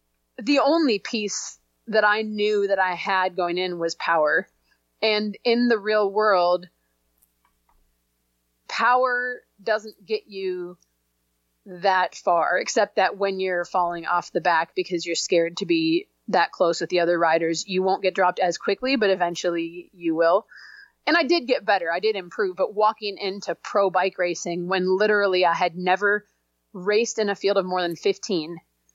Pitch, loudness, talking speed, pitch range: 185 Hz, -23 LUFS, 165 wpm, 175-210 Hz